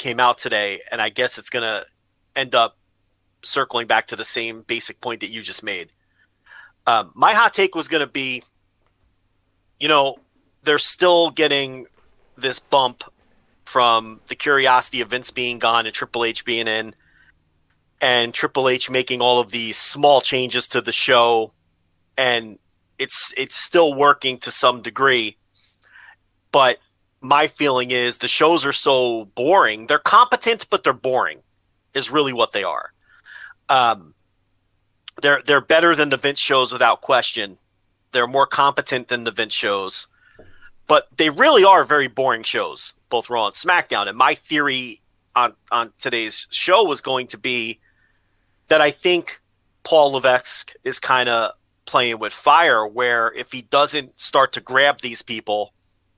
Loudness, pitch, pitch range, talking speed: -18 LUFS, 125 Hz, 110-140 Hz, 155 wpm